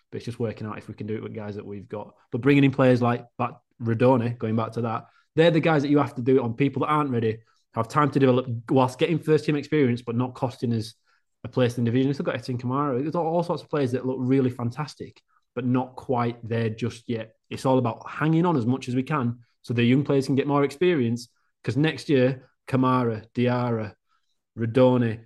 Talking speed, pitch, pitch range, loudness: 240 wpm, 125 Hz, 115-140 Hz, -24 LUFS